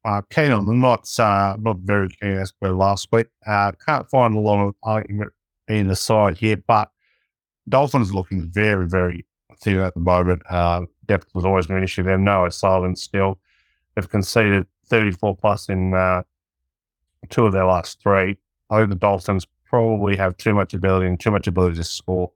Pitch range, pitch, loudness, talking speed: 90-105 Hz, 100 Hz, -20 LUFS, 190 wpm